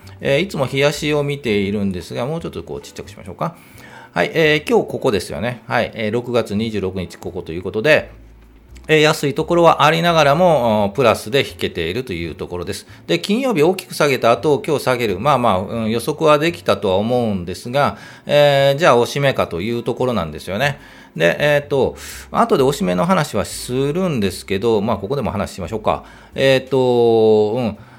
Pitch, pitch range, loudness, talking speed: 125 Hz, 100-150 Hz, -17 LUFS, 390 characters per minute